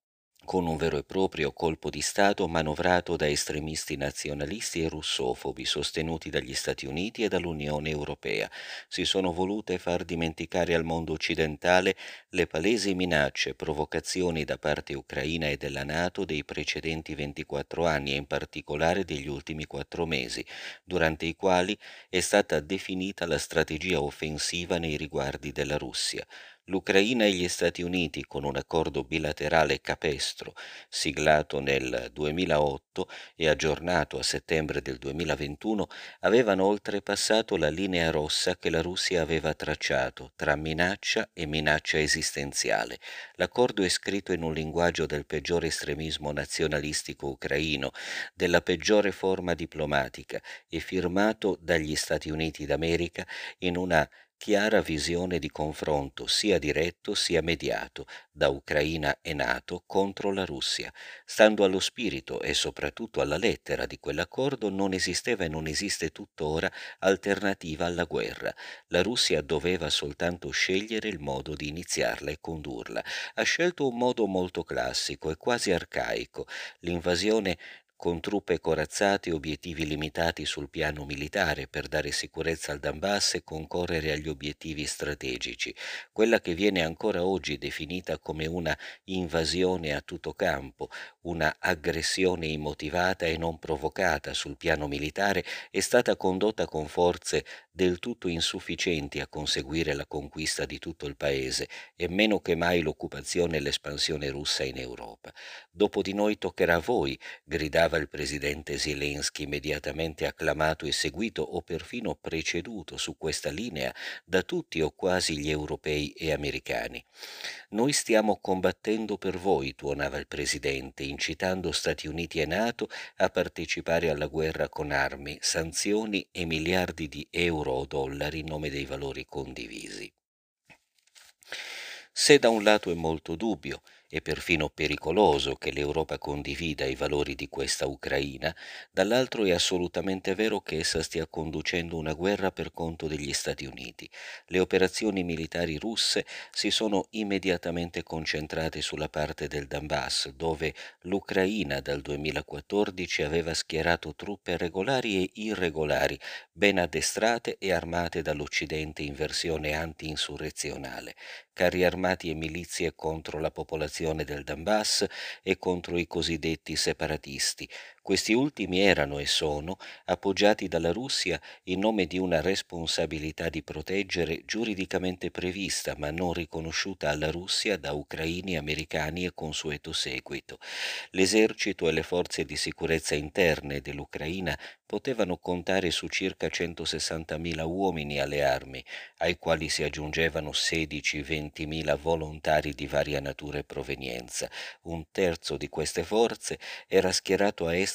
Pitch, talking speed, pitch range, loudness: 80 Hz, 135 wpm, 75-95 Hz, -29 LUFS